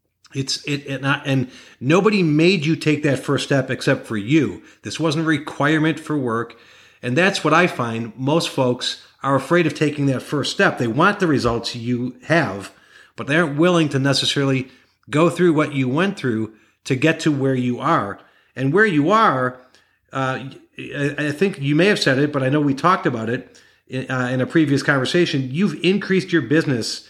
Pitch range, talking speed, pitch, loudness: 130-160 Hz, 195 wpm, 140 Hz, -19 LUFS